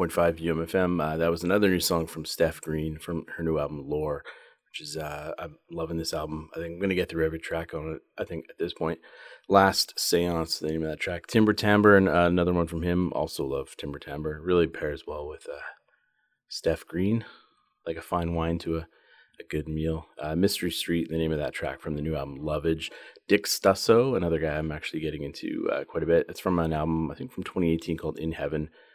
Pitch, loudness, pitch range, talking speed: 80 Hz, -27 LUFS, 80-90 Hz, 225 wpm